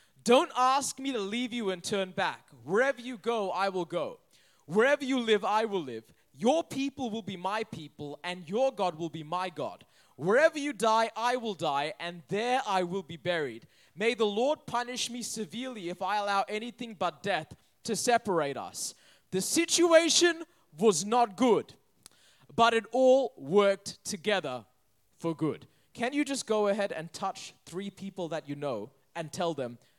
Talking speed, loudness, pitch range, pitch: 175 wpm, -30 LUFS, 175-245 Hz, 210 Hz